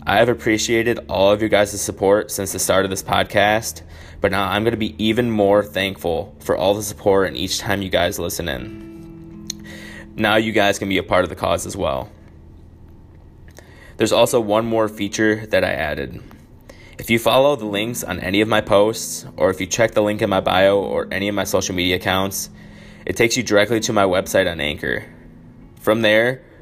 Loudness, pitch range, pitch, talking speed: -19 LUFS, 95-110 Hz, 105 Hz, 205 wpm